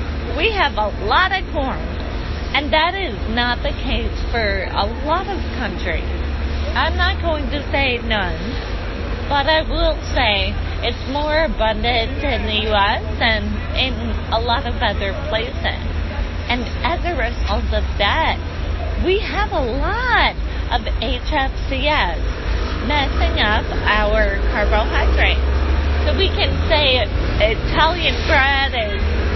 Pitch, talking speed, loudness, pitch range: 80 Hz, 130 wpm, -19 LUFS, 75-85 Hz